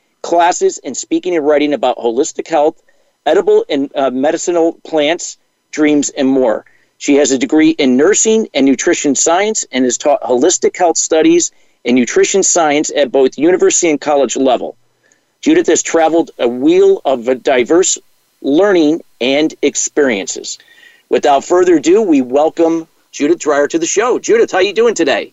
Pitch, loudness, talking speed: 210 Hz, -12 LUFS, 160 wpm